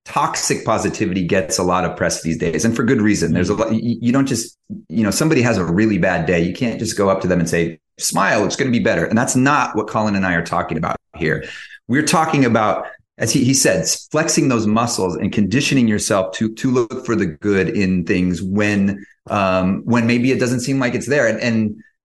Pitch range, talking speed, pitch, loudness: 95-125 Hz, 235 wpm, 110 Hz, -17 LUFS